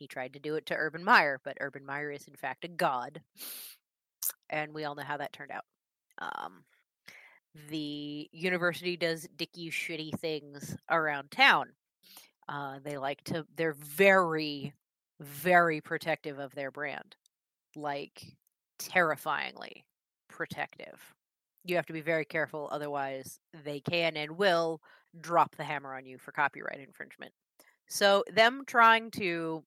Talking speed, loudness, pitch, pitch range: 140 wpm, -31 LUFS, 155 Hz, 145-170 Hz